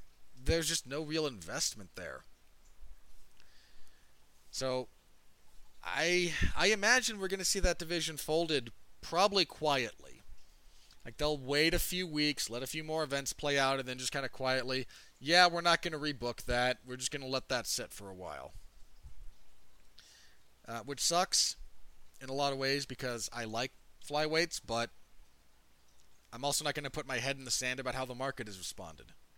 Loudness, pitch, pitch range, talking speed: -33 LUFS, 130 Hz, 100-150 Hz, 175 wpm